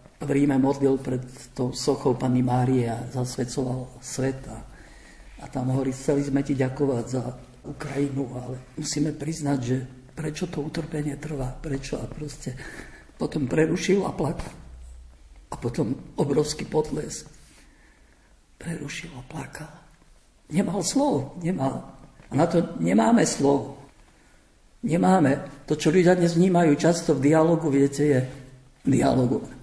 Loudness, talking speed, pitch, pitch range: -25 LUFS, 125 wpm, 140 Hz, 130-155 Hz